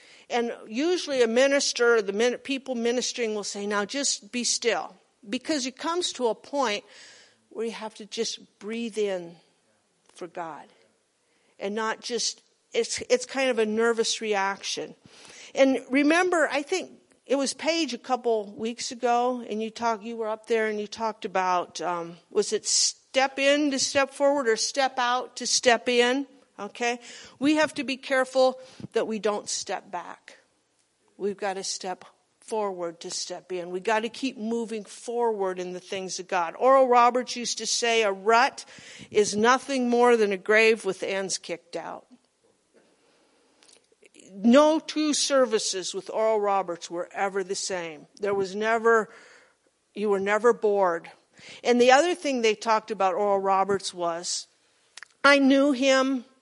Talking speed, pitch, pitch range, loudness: 160 wpm, 230 Hz, 205-265 Hz, -25 LUFS